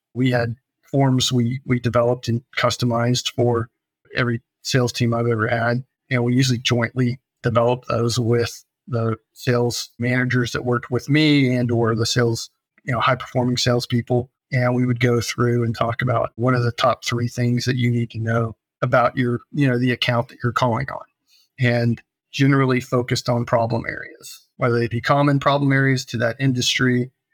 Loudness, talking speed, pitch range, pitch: -20 LUFS, 180 wpm, 120-125 Hz, 120 Hz